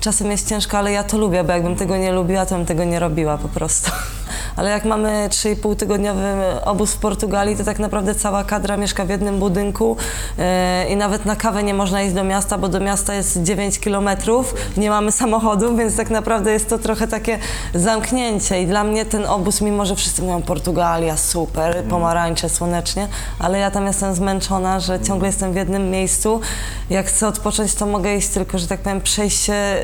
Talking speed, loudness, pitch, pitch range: 195 wpm, -18 LUFS, 200 Hz, 185-210 Hz